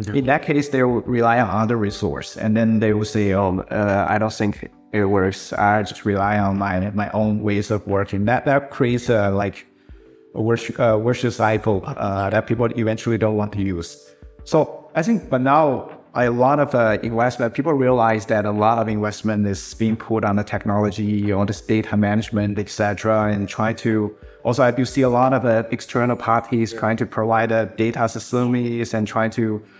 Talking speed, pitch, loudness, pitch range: 205 wpm, 110 Hz, -20 LUFS, 105-120 Hz